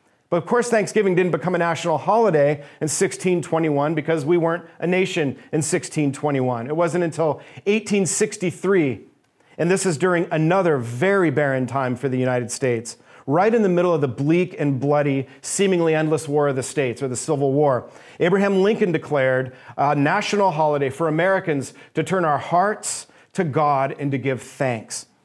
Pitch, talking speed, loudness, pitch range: 160 Hz, 165 wpm, -21 LUFS, 140-180 Hz